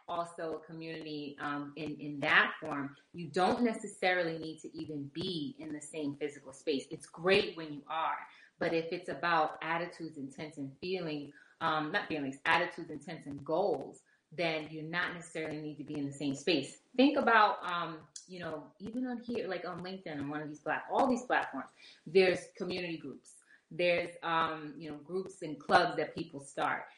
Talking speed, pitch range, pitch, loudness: 190 wpm, 150-175 Hz, 160 Hz, -34 LUFS